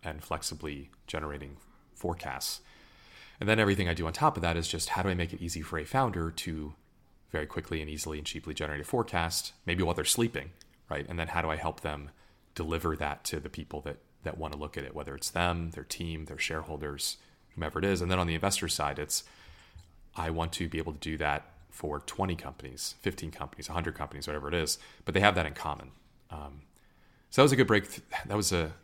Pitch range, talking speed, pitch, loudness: 75-90 Hz, 230 wpm, 80 Hz, -32 LUFS